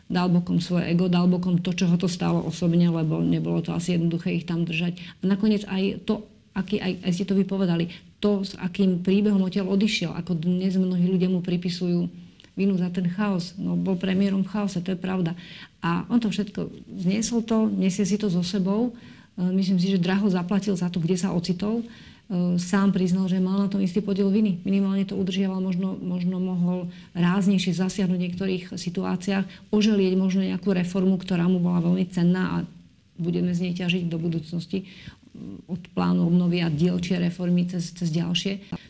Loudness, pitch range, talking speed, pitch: -24 LUFS, 175-195 Hz, 185 wpm, 185 Hz